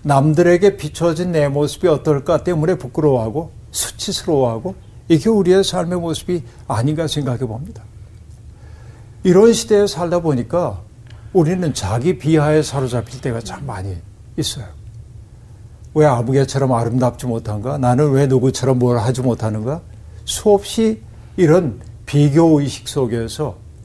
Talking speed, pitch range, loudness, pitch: 295 characters per minute, 115-165 Hz, -17 LUFS, 135 Hz